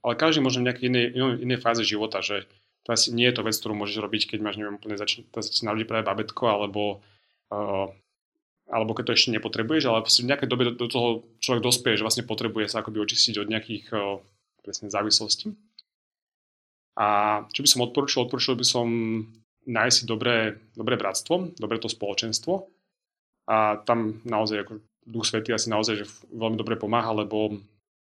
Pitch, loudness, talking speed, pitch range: 110 Hz, -25 LUFS, 180 wpm, 105-120 Hz